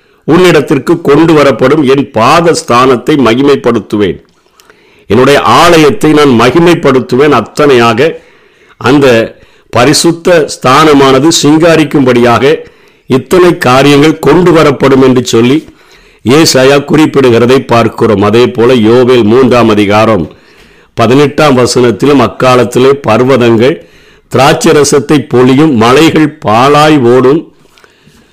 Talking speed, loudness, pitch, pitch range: 85 wpm, -5 LUFS, 140 Hz, 125-155 Hz